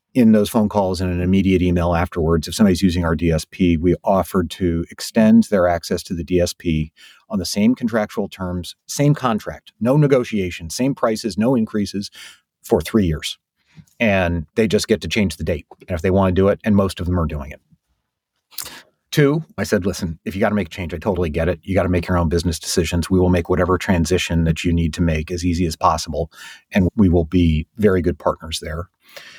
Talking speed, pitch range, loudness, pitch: 215 wpm, 85-100 Hz, -19 LUFS, 90 Hz